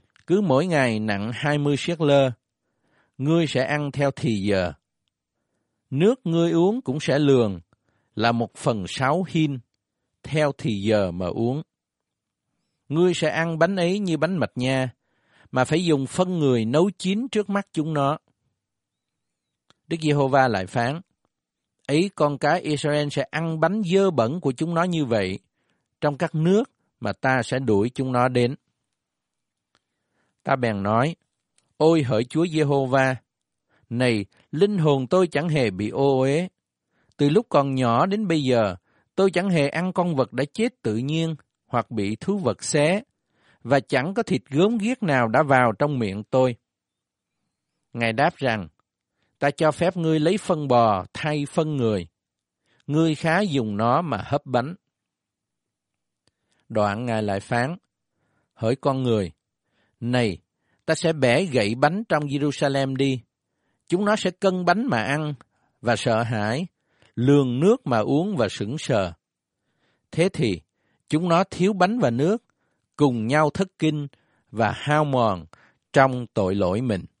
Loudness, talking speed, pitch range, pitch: -23 LUFS, 155 wpm, 115-160 Hz, 140 Hz